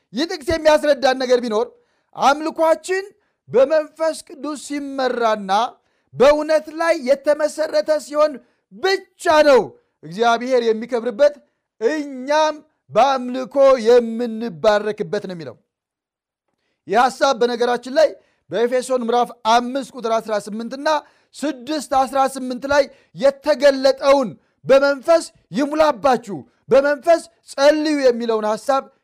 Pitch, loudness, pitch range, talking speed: 275 Hz, -18 LUFS, 245-305 Hz, 85 wpm